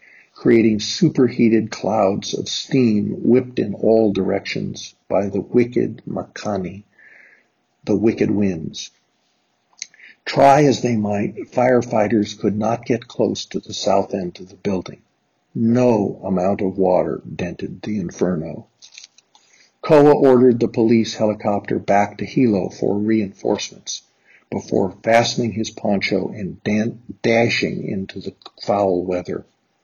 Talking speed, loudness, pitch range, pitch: 120 wpm, -19 LUFS, 100-120 Hz, 110 Hz